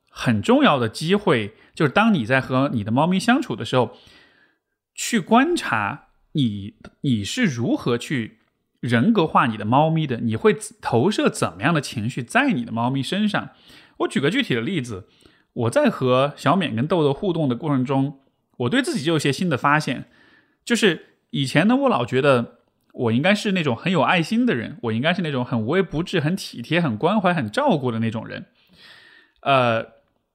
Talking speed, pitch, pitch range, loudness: 265 characters per minute, 145 Hz, 120-190 Hz, -21 LUFS